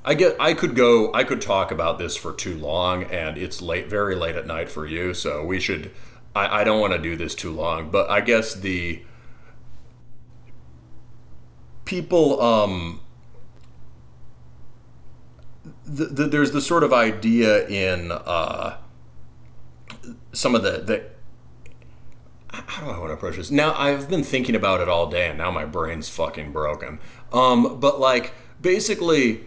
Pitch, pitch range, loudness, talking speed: 105 Hz, 75-125 Hz, -22 LUFS, 155 wpm